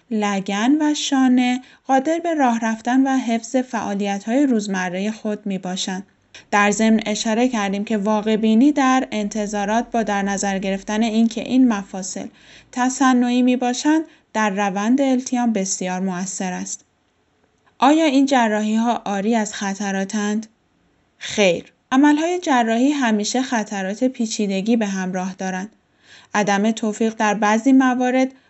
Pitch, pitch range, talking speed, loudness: 220 Hz, 205-255 Hz, 125 wpm, -19 LUFS